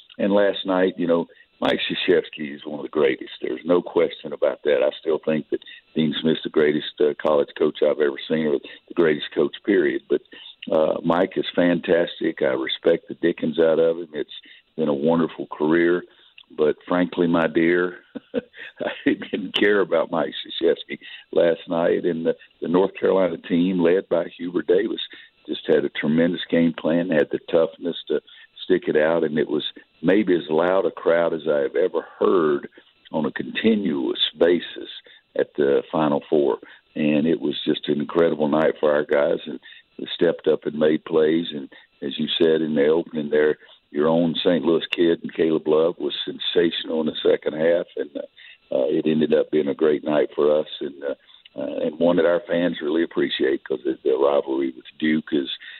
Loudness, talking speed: -22 LUFS, 190 wpm